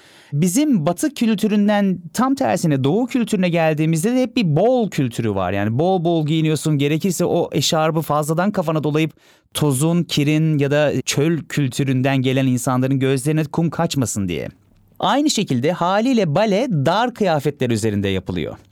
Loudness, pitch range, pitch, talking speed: -18 LUFS, 135-190 Hz, 160 Hz, 140 wpm